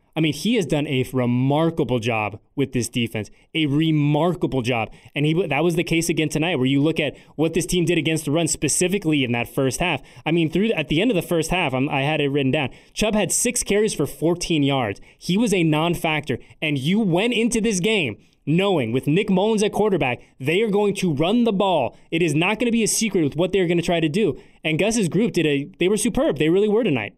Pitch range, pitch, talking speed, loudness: 140-190 Hz, 160 Hz, 245 wpm, -21 LUFS